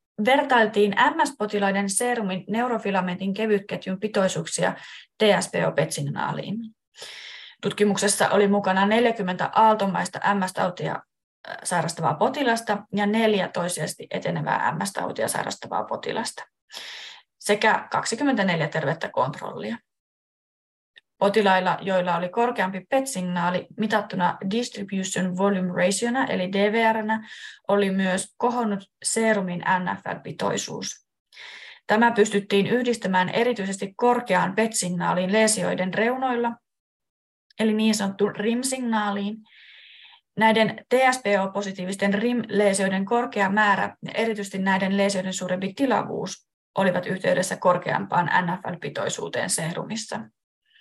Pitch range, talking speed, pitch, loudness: 190-225 Hz, 85 wpm, 205 Hz, -23 LUFS